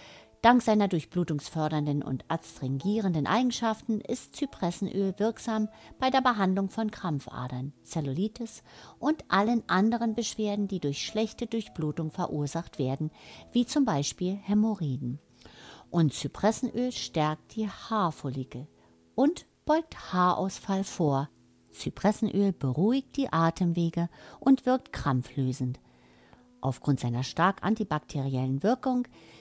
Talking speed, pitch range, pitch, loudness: 100 wpm, 140-220 Hz, 180 Hz, -29 LUFS